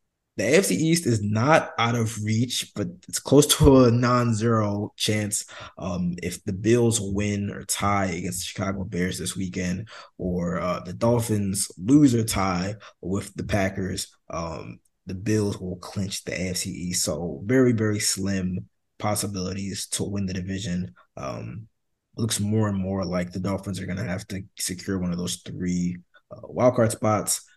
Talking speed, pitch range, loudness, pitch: 170 wpm, 90-110 Hz, -24 LUFS, 100 Hz